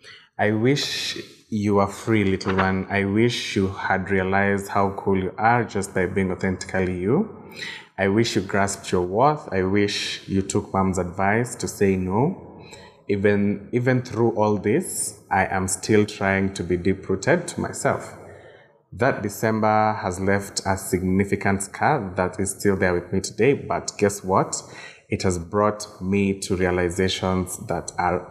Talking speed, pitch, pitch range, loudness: 160 wpm, 100 Hz, 95-105 Hz, -23 LUFS